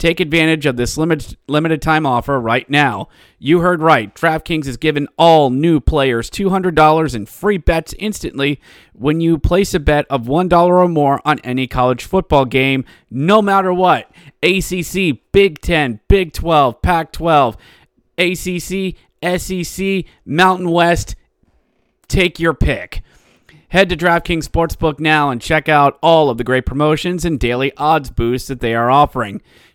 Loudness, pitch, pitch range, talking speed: -15 LUFS, 155 Hz, 135-175 Hz, 155 wpm